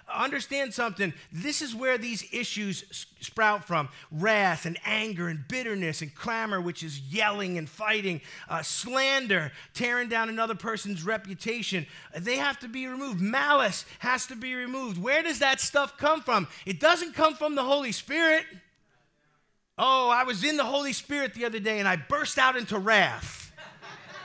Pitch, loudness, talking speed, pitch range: 225 Hz, -27 LUFS, 165 wpm, 195-270 Hz